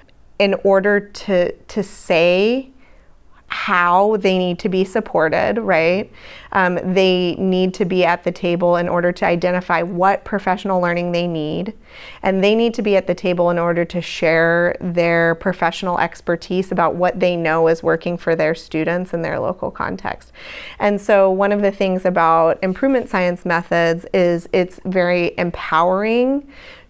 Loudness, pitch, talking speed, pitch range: -17 LUFS, 180 Hz, 160 wpm, 170-195 Hz